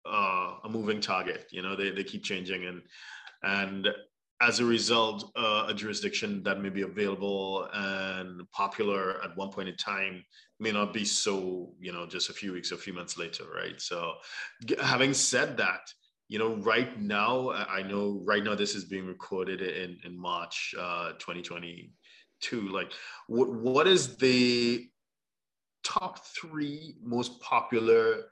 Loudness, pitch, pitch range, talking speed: -30 LUFS, 100 Hz, 95-120 Hz, 160 wpm